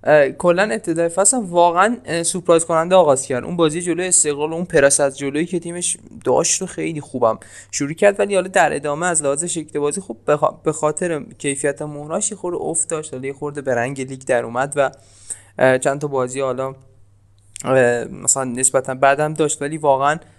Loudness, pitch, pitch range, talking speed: -18 LUFS, 150 Hz, 130-170 Hz, 170 wpm